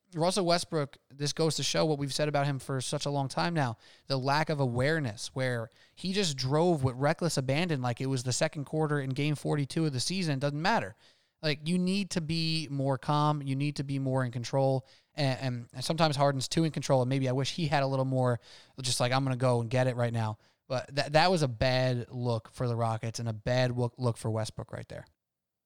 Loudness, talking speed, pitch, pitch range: -30 LUFS, 240 wpm, 135 Hz, 125-155 Hz